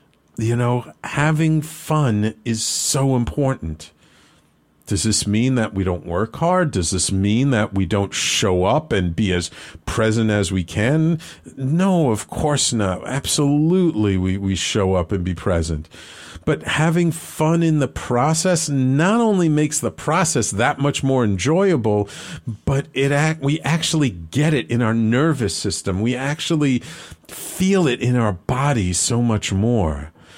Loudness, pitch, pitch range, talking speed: -19 LUFS, 115 Hz, 95-150 Hz, 155 wpm